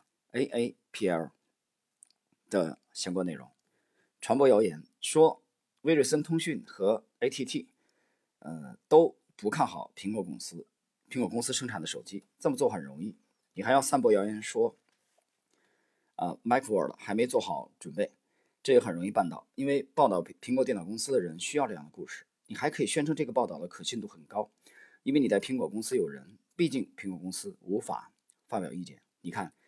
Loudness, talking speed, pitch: -30 LUFS, 275 characters per minute, 160 Hz